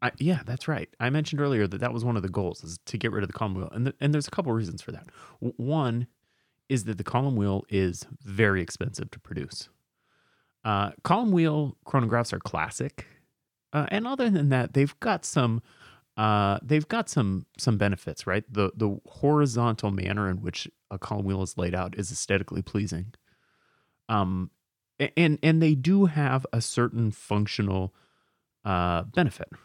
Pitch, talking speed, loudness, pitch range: 115 Hz, 180 wpm, -27 LUFS, 100-140 Hz